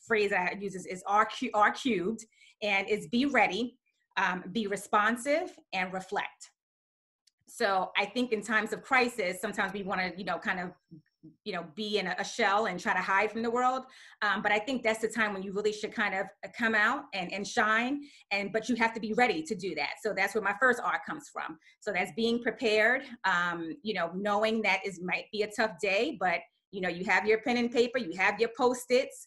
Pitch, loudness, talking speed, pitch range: 210 Hz, -30 LUFS, 225 wpm, 190-230 Hz